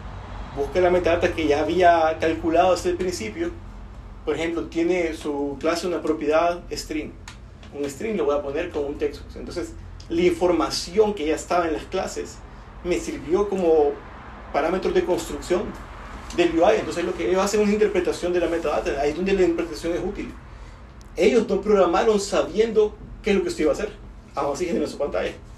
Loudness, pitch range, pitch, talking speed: -23 LUFS, 150-185 Hz, 170 Hz, 185 wpm